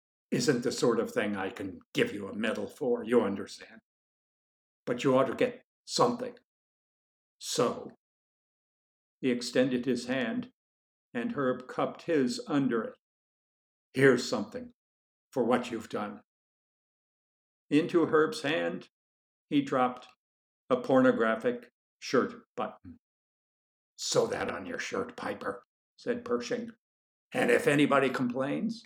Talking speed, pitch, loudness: 120 wpm, 140 Hz, -30 LUFS